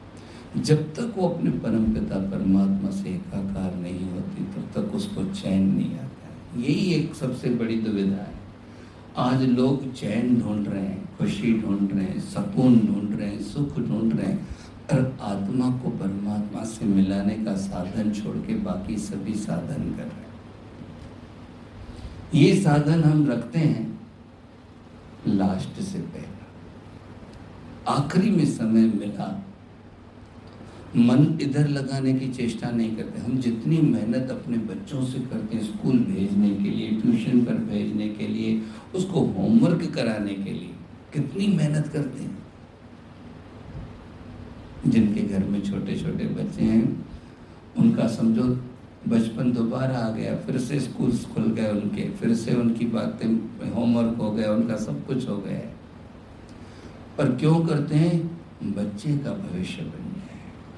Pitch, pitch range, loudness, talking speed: 115 Hz, 105-145 Hz, -25 LUFS, 140 wpm